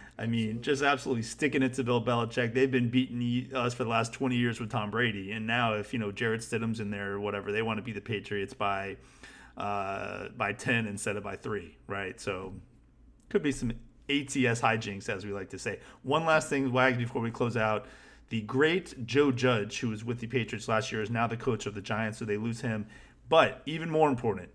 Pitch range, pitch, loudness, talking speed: 110-130 Hz, 115 Hz, -30 LUFS, 225 wpm